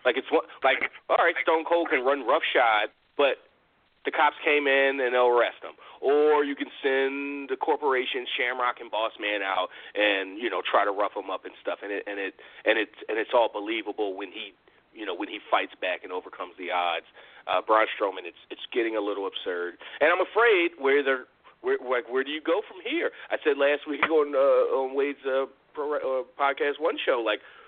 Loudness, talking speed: -26 LUFS, 225 wpm